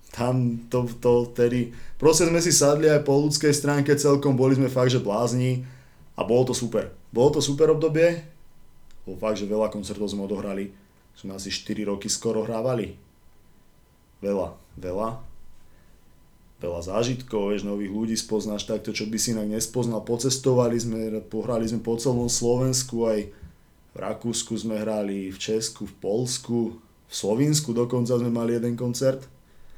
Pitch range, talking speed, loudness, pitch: 105-125 Hz, 155 wpm, -24 LUFS, 115 Hz